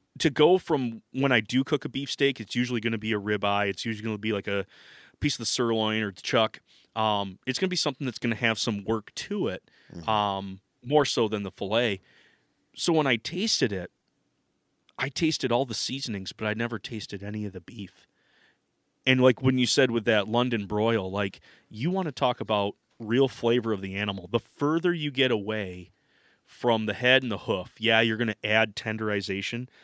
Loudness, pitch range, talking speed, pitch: -27 LUFS, 105-130 Hz, 200 wpm, 115 Hz